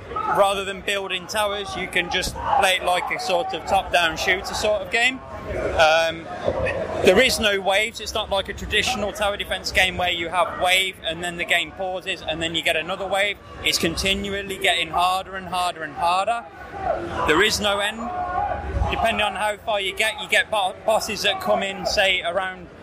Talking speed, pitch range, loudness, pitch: 195 wpm, 180-205 Hz, -21 LUFS, 195 Hz